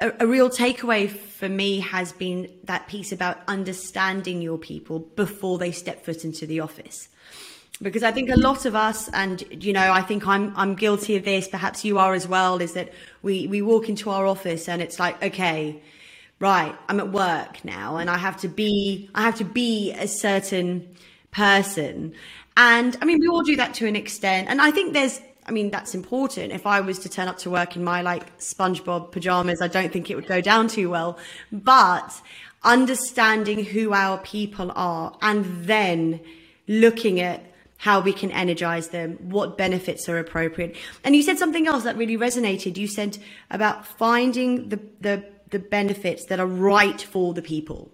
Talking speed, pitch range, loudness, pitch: 190 wpm, 180-215 Hz, -22 LUFS, 195 Hz